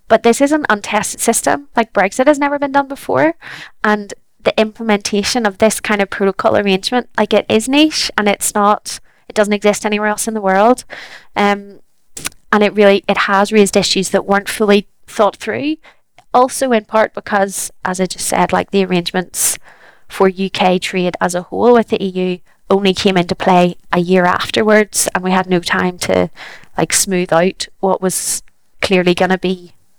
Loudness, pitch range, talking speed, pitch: -14 LUFS, 185-220 Hz, 185 wpm, 205 Hz